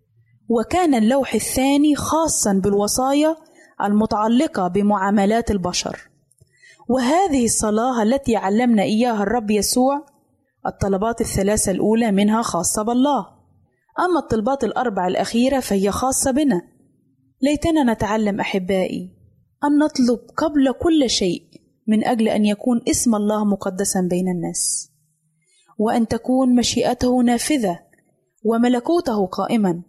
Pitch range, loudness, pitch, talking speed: 200-260 Hz, -19 LUFS, 225 Hz, 100 wpm